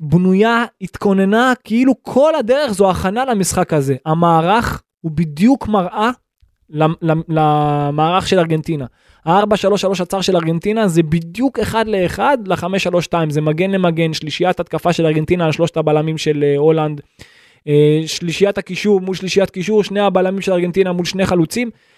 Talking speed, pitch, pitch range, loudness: 135 wpm, 180 Hz, 160-200 Hz, -15 LUFS